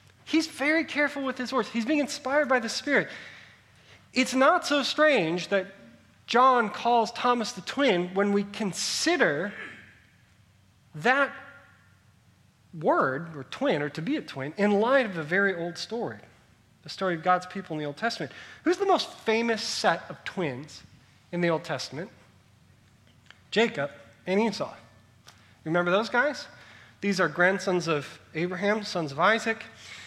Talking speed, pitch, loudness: 150 wpm, 195 Hz, -26 LUFS